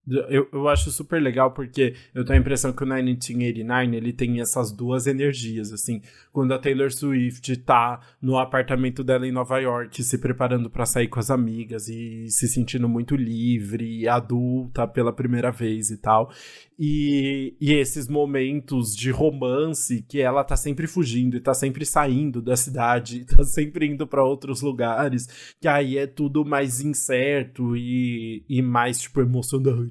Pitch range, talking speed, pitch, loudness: 120-140 Hz, 165 wpm, 130 Hz, -23 LUFS